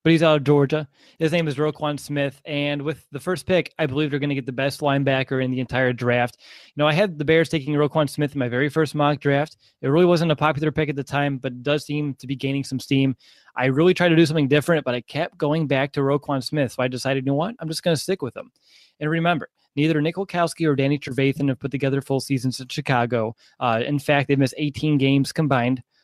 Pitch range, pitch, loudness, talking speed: 135-155 Hz, 145 Hz, -22 LUFS, 255 wpm